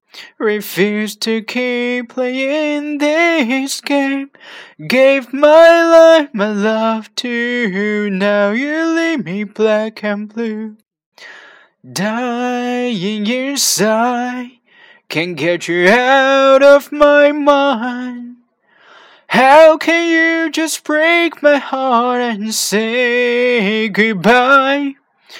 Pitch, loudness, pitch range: 245 Hz, -13 LUFS, 215-290 Hz